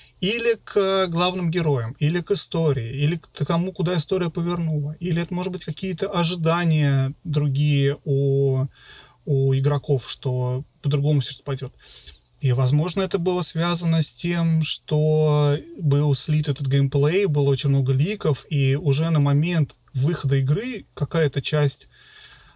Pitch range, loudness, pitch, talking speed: 140-170 Hz, -21 LUFS, 150 Hz, 135 wpm